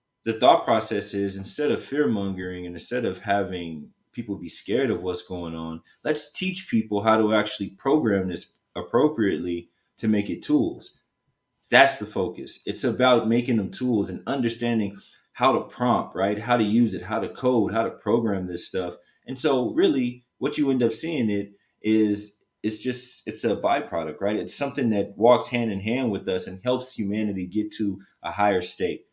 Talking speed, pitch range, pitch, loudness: 185 wpm, 95-125 Hz, 110 Hz, -25 LUFS